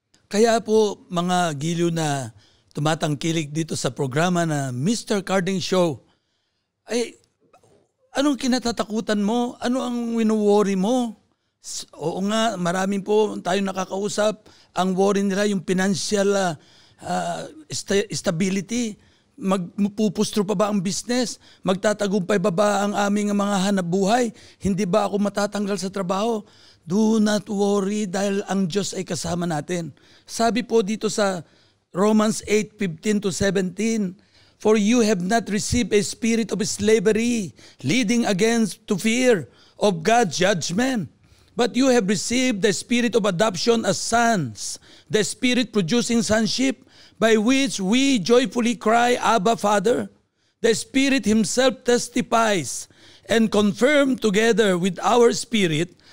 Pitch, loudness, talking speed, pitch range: 210 Hz, -21 LUFS, 125 wpm, 185-230 Hz